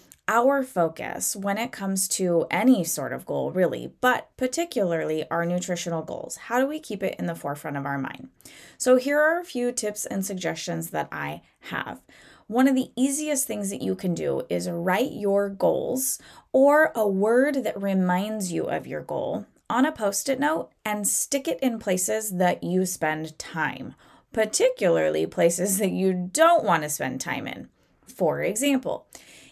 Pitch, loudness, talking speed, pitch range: 205 Hz, -25 LUFS, 175 wpm, 180-260 Hz